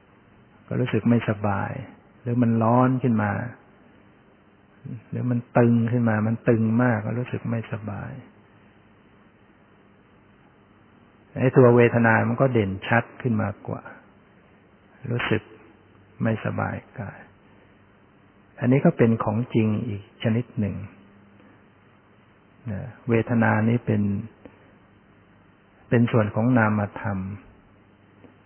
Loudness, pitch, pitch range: -23 LUFS, 110 Hz, 100-120 Hz